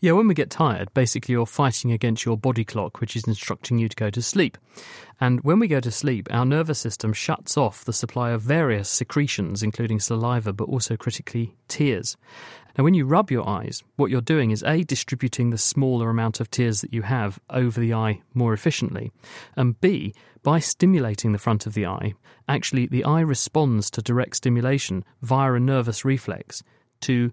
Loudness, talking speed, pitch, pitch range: -23 LUFS, 195 wpm, 120 Hz, 115-135 Hz